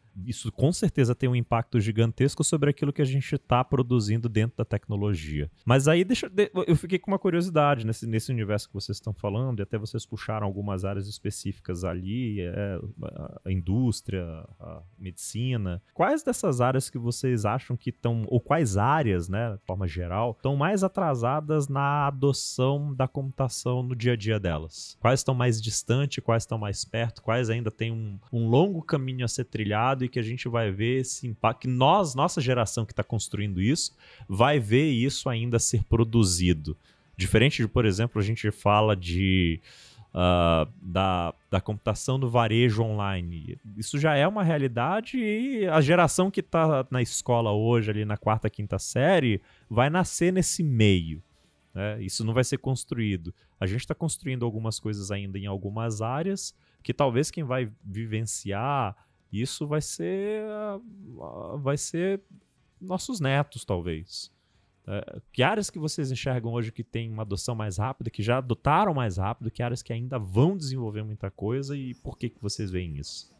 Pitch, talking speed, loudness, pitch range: 120 Hz, 170 wpm, -27 LUFS, 105-135 Hz